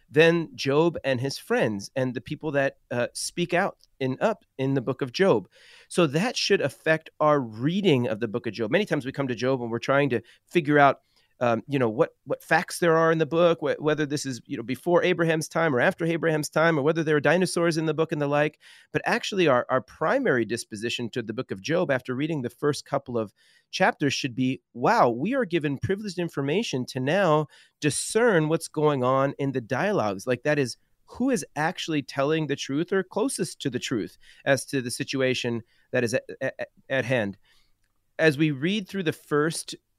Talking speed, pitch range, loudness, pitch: 215 wpm, 130-165 Hz, -25 LUFS, 145 Hz